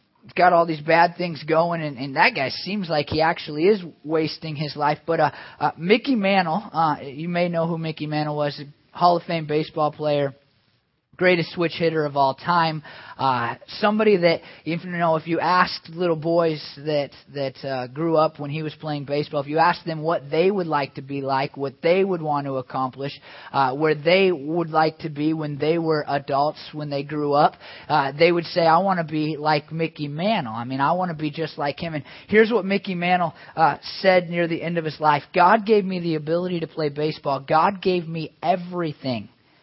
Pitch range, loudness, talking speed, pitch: 145-170 Hz, -22 LUFS, 210 wpm, 155 Hz